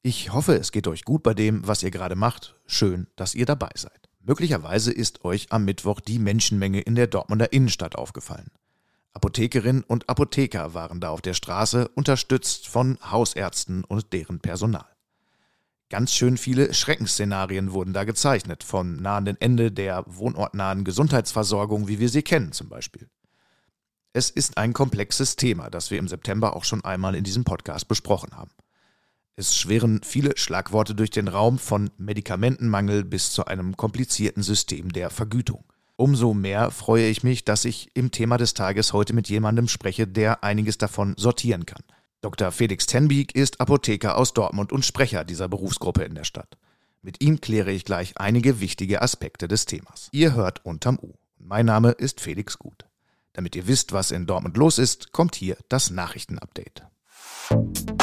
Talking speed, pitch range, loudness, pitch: 165 wpm, 95-120 Hz, -23 LUFS, 110 Hz